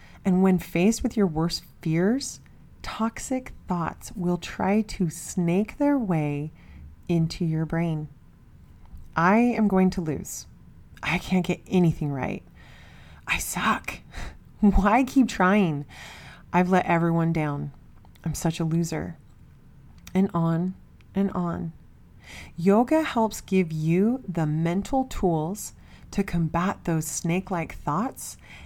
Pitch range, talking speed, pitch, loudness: 155-195 Hz, 120 wpm, 170 Hz, -25 LUFS